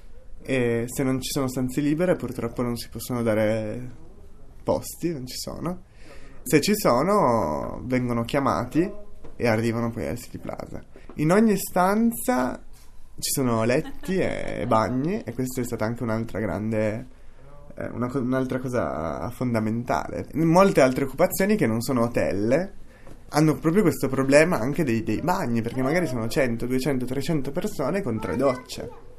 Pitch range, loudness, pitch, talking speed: 115-150 Hz, -24 LUFS, 130 Hz, 150 wpm